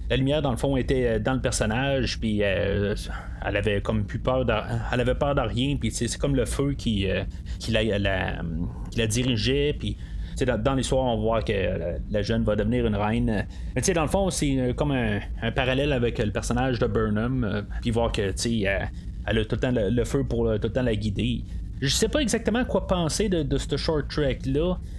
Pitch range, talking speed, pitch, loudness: 105-135 Hz, 225 wpm, 120 Hz, -25 LUFS